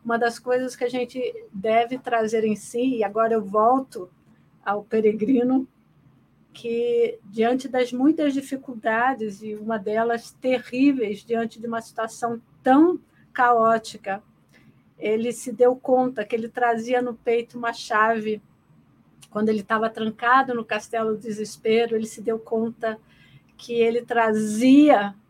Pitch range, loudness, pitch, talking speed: 220-245 Hz, -23 LUFS, 230 Hz, 135 wpm